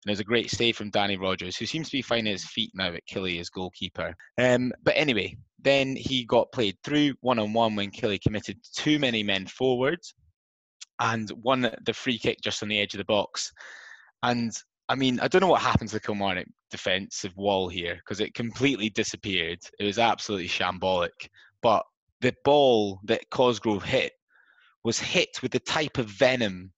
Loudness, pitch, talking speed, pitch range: -26 LUFS, 115 Hz, 185 wpm, 100-130 Hz